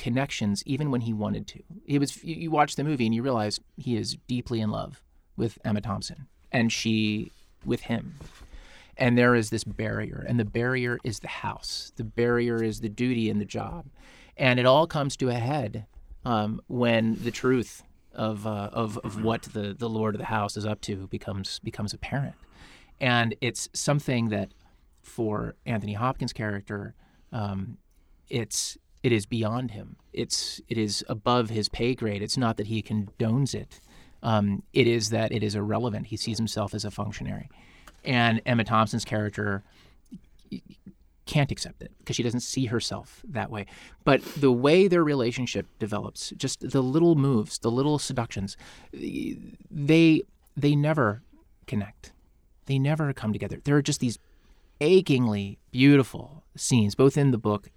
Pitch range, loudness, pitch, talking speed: 105-130 Hz, -27 LUFS, 115 Hz, 165 wpm